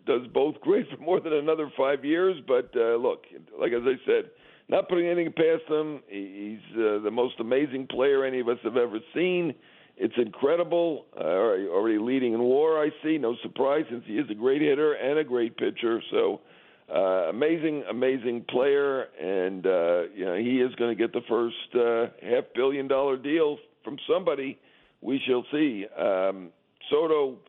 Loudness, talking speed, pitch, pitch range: -26 LUFS, 185 wpm, 140 Hz, 120-180 Hz